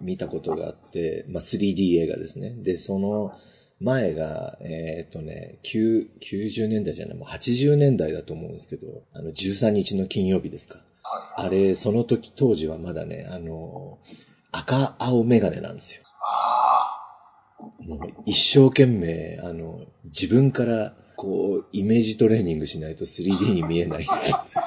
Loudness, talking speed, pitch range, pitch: -23 LUFS, 270 characters per minute, 85-120 Hz, 105 Hz